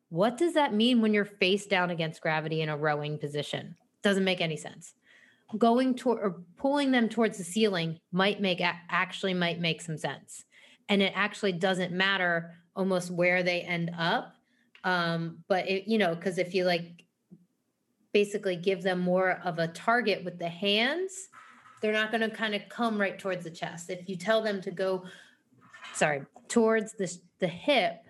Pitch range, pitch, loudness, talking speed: 175-220 Hz, 190 Hz, -29 LUFS, 175 wpm